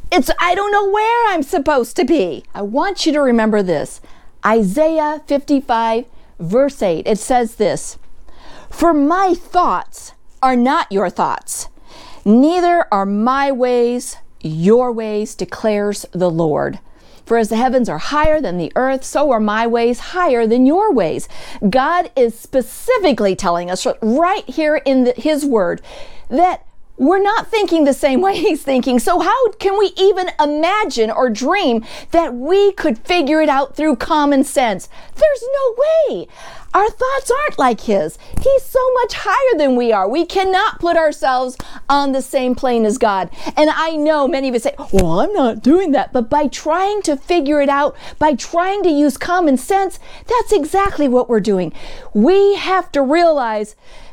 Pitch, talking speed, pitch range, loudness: 290 Hz, 165 wpm, 240-350 Hz, -15 LUFS